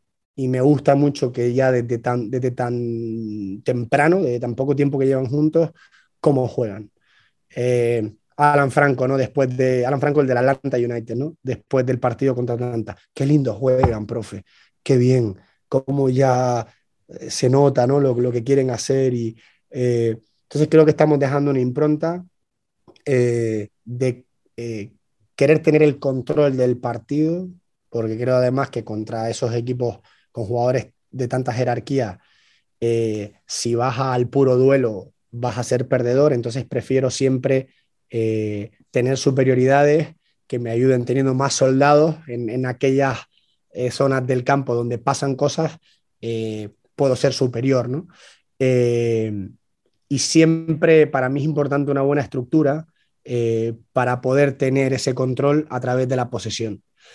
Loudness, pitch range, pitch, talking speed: -20 LUFS, 120-140 Hz, 130 Hz, 150 wpm